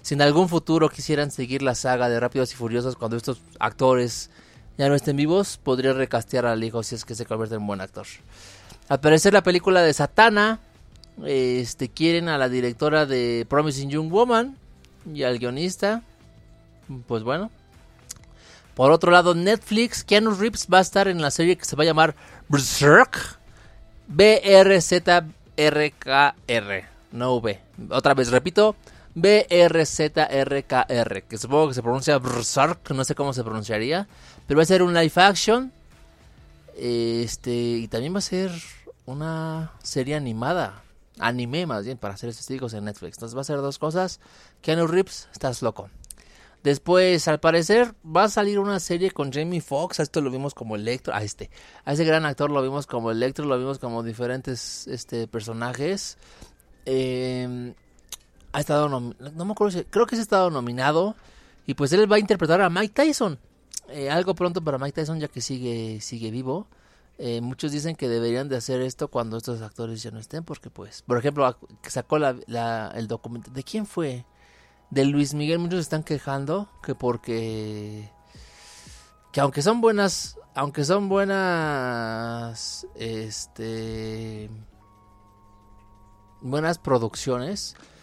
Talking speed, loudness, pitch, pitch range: 160 wpm, -22 LUFS, 135 Hz, 115-165 Hz